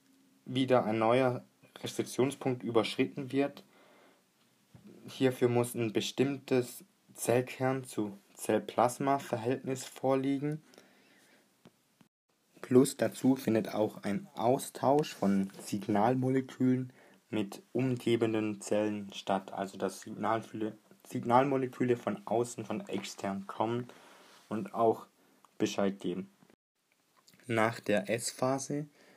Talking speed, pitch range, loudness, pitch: 85 wpm, 110-130 Hz, -32 LUFS, 120 Hz